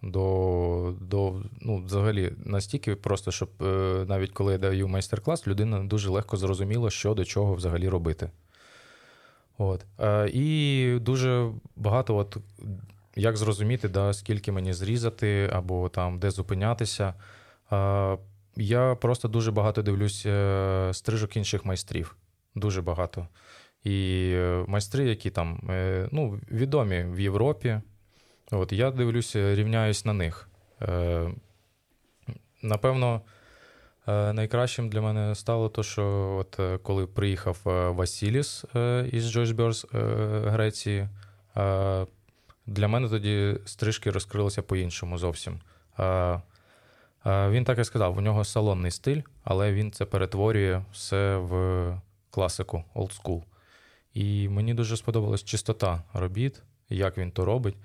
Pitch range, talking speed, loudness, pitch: 95-110 Hz, 110 wpm, -28 LUFS, 100 Hz